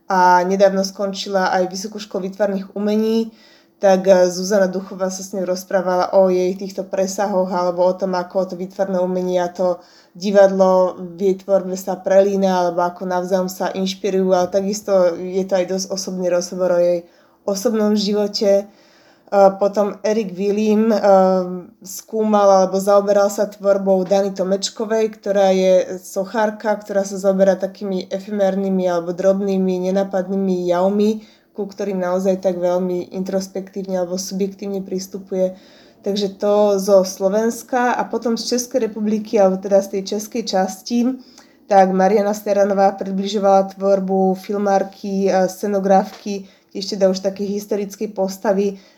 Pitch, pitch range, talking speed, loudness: 195 Hz, 185-205 Hz, 135 wpm, -18 LUFS